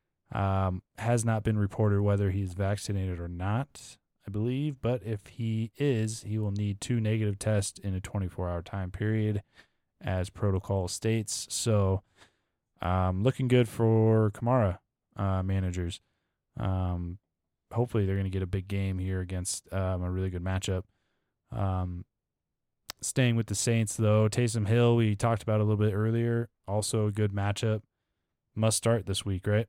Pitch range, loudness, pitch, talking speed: 95-110 Hz, -30 LUFS, 105 Hz, 160 wpm